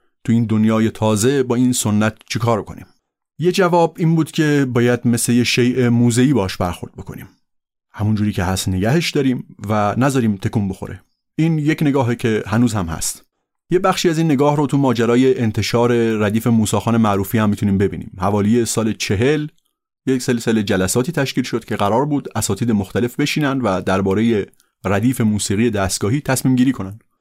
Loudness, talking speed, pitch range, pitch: -17 LUFS, 170 wpm, 105-130 Hz, 120 Hz